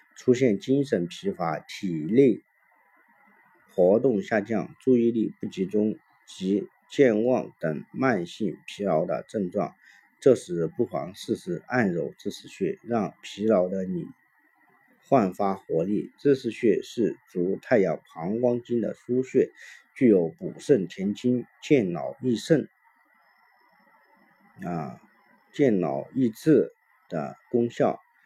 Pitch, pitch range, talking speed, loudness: 115 Hz, 100-130 Hz, 170 characters per minute, -26 LUFS